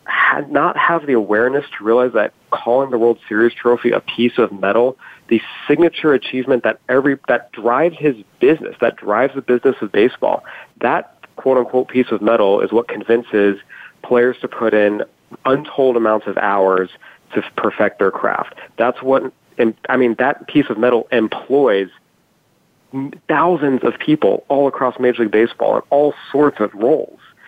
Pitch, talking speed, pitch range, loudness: 125 Hz, 165 wpm, 110-135 Hz, -16 LUFS